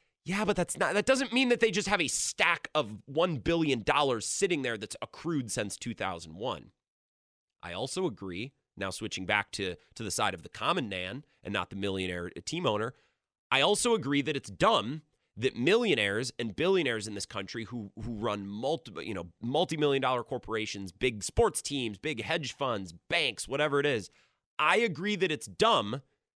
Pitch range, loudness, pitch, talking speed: 100-160 Hz, -30 LUFS, 125 Hz, 190 wpm